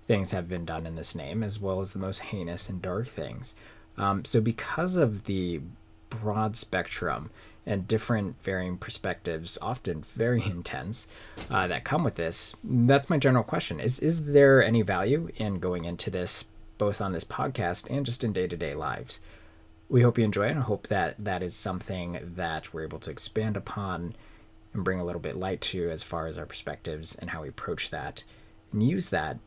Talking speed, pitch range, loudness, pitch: 195 wpm, 85-115 Hz, -29 LUFS, 100 Hz